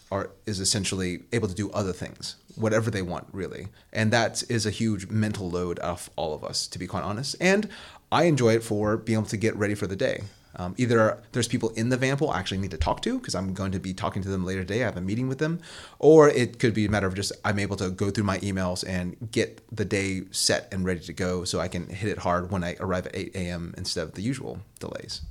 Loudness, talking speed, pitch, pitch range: -26 LUFS, 260 wpm, 100 Hz, 95-115 Hz